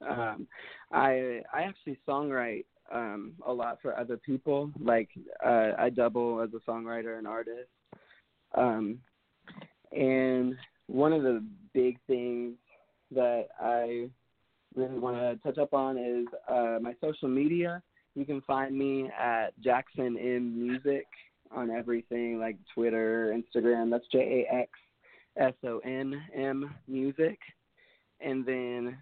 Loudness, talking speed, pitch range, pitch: -31 LUFS, 130 wpm, 120-135 Hz, 125 Hz